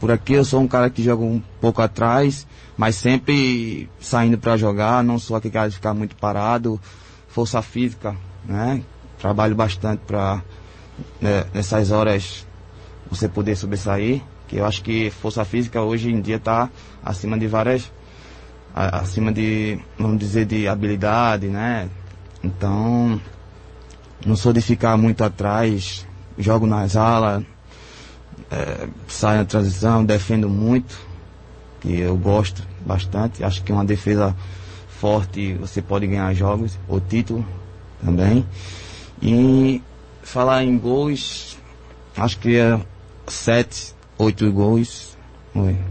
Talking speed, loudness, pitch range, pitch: 135 wpm, -20 LUFS, 95-115 Hz, 105 Hz